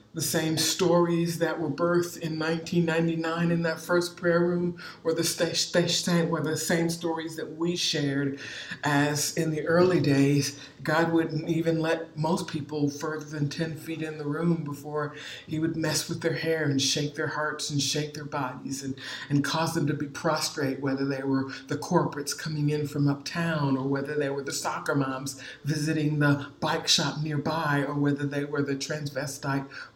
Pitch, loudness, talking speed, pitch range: 155 Hz, -27 LUFS, 175 wpm, 145-165 Hz